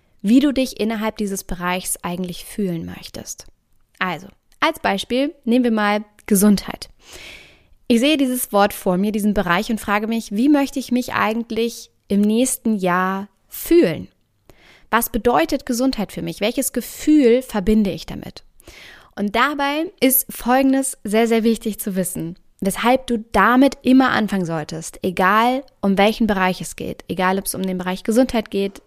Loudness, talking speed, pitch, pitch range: -19 LUFS, 155 wpm, 220 Hz, 195-250 Hz